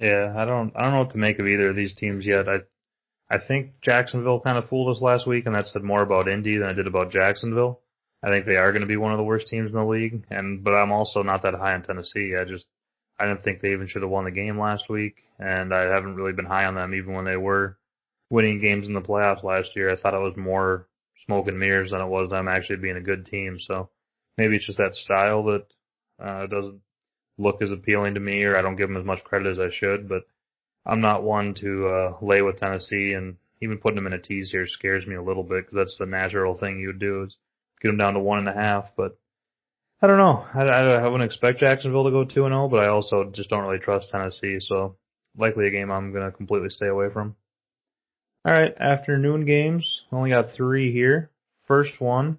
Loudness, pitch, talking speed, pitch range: -23 LUFS, 100 Hz, 250 wpm, 95-110 Hz